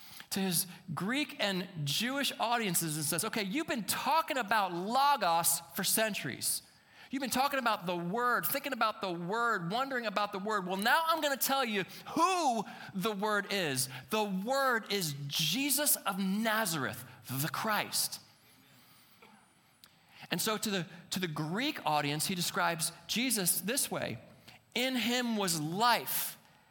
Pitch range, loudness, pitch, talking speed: 175-245 Hz, -32 LUFS, 205 Hz, 150 wpm